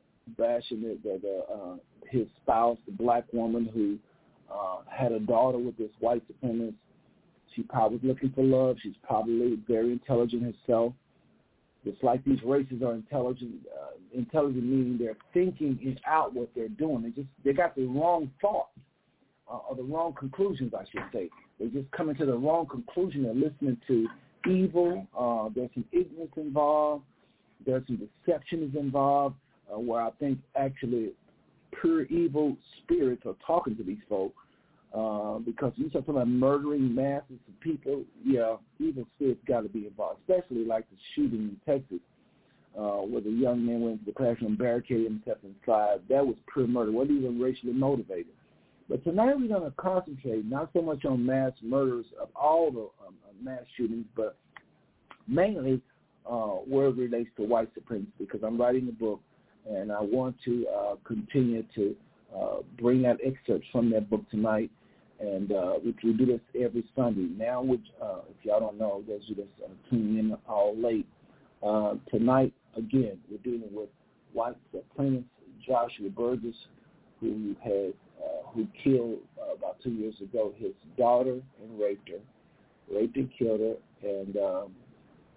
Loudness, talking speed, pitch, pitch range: -30 LUFS, 170 wpm, 125 Hz, 115-135 Hz